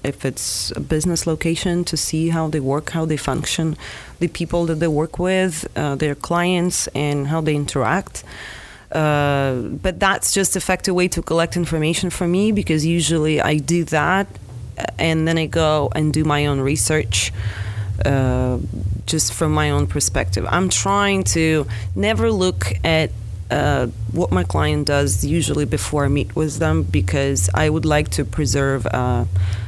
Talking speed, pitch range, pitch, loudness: 165 wpm, 110-165 Hz, 150 Hz, -19 LUFS